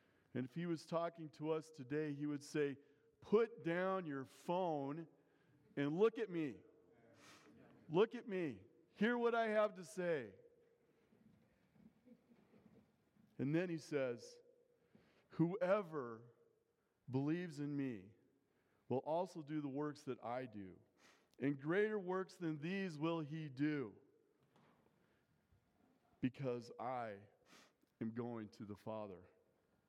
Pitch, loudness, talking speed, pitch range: 155 Hz, -43 LUFS, 120 wpm, 140-190 Hz